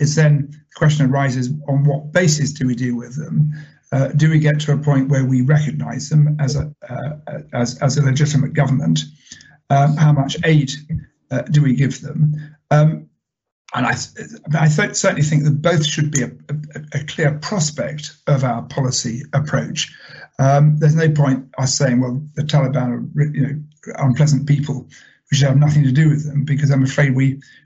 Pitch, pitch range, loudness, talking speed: 145 Hz, 135-150 Hz, -17 LUFS, 190 wpm